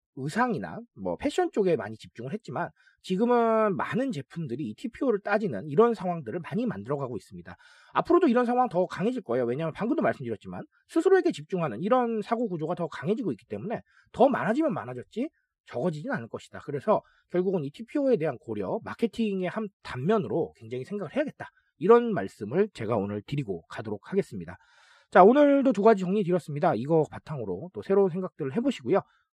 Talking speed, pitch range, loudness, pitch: 430 characters per minute, 160-240 Hz, -27 LUFS, 205 Hz